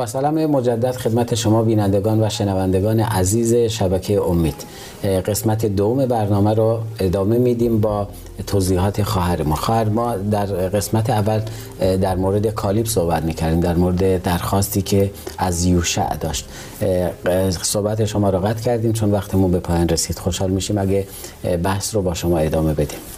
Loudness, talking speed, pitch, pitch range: -19 LUFS, 145 wpm, 100 Hz, 90-110 Hz